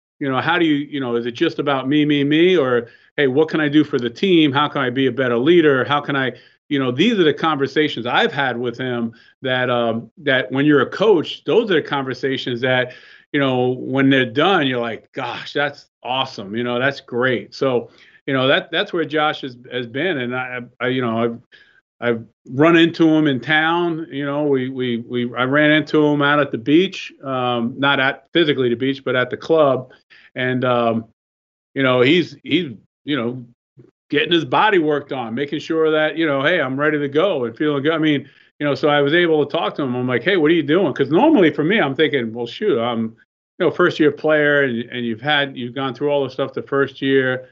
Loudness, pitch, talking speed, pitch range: -18 LUFS, 135 Hz, 235 wpm, 125-150 Hz